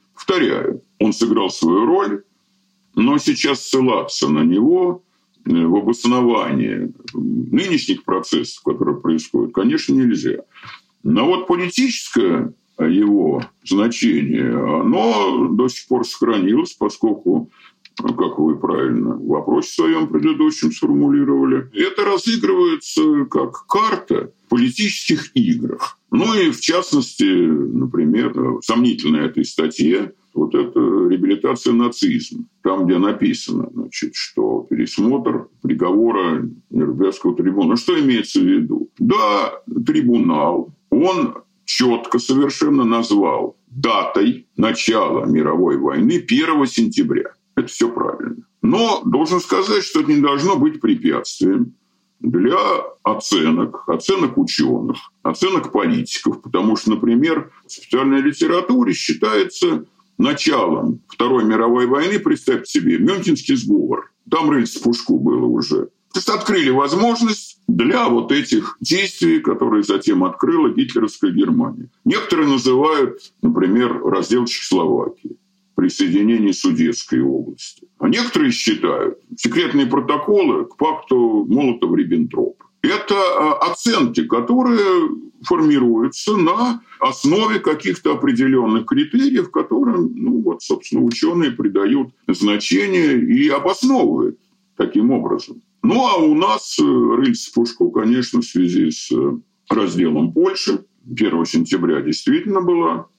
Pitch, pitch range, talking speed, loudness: 295 Hz, 250-340 Hz, 105 wpm, -17 LUFS